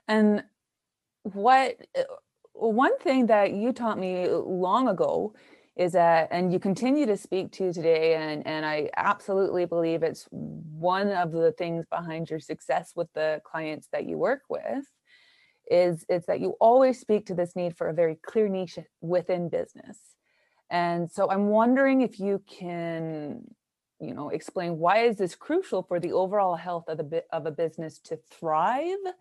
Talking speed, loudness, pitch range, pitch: 165 wpm, -26 LUFS, 165-225 Hz, 180 Hz